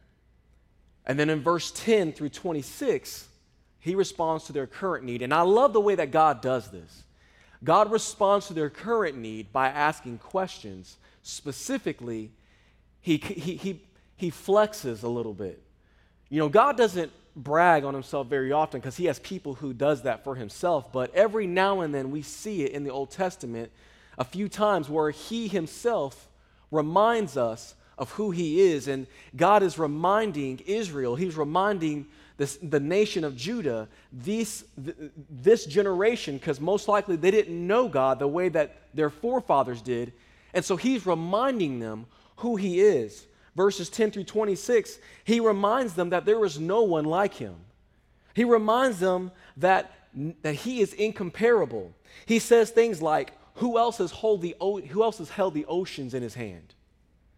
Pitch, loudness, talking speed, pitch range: 170 Hz, -26 LUFS, 165 wpm, 135-205 Hz